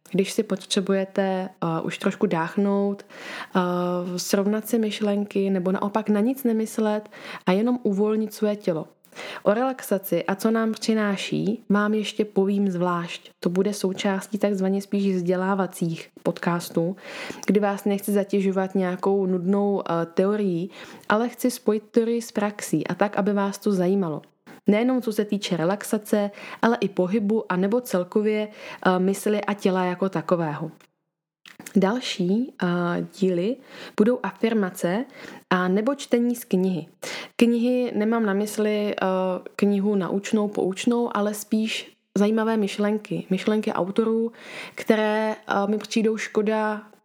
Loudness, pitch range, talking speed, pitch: -24 LUFS, 190-215 Hz, 130 wpm, 205 Hz